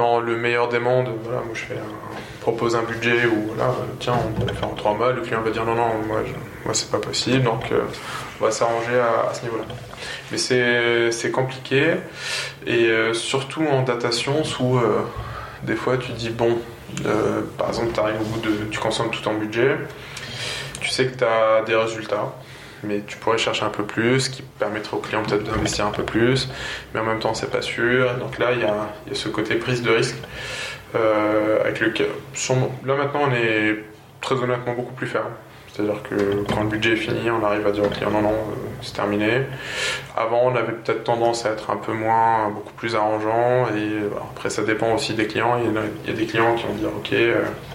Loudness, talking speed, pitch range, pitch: -22 LUFS, 220 wpm, 110-125 Hz, 115 Hz